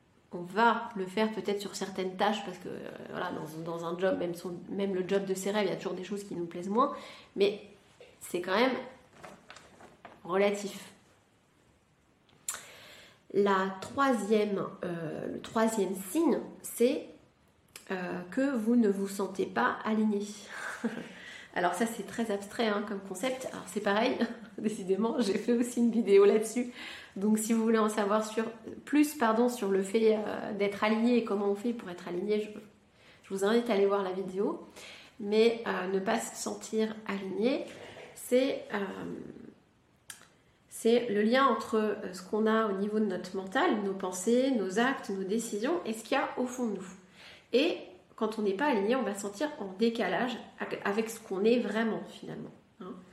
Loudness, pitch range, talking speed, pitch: -31 LUFS, 195-230 Hz, 175 wpm, 215 Hz